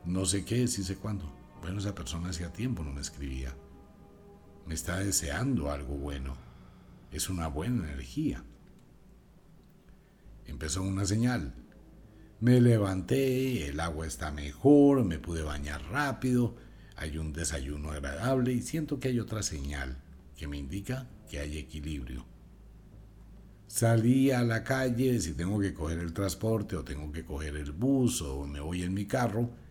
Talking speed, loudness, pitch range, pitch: 150 wpm, -31 LUFS, 75-115 Hz, 90 Hz